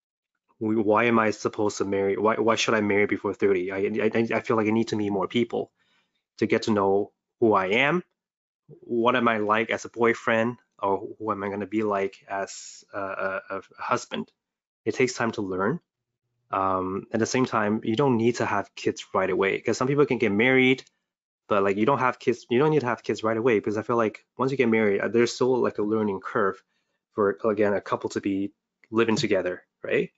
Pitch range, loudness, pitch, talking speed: 105-120 Hz, -25 LUFS, 110 Hz, 225 wpm